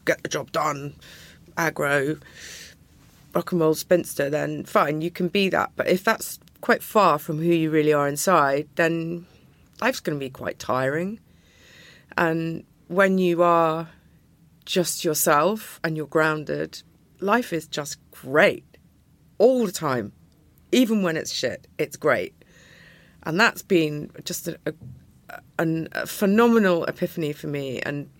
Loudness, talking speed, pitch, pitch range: -23 LUFS, 145 wpm, 165 Hz, 150-180 Hz